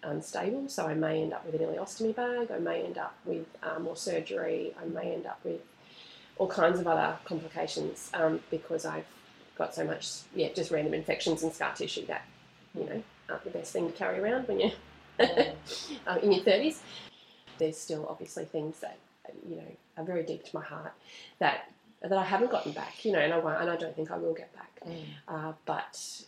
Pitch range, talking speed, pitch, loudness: 160-195 Hz, 210 wpm, 165 Hz, -32 LUFS